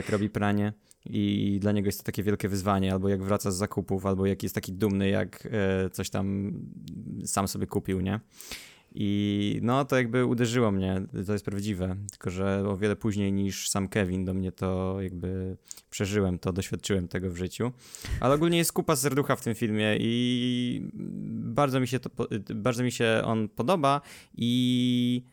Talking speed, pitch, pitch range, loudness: 175 wpm, 105 Hz, 95-120 Hz, -28 LUFS